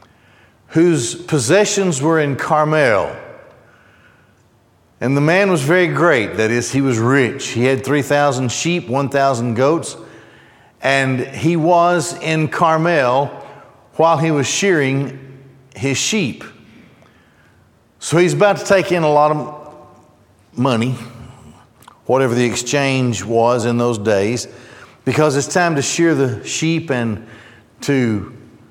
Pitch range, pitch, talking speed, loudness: 120-160 Hz, 135 Hz, 125 wpm, -16 LUFS